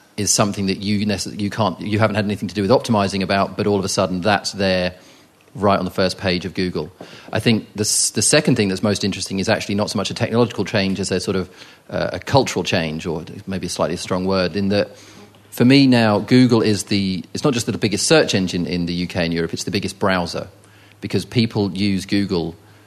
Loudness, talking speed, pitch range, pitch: -19 LUFS, 235 wpm, 95-105 Hz, 100 Hz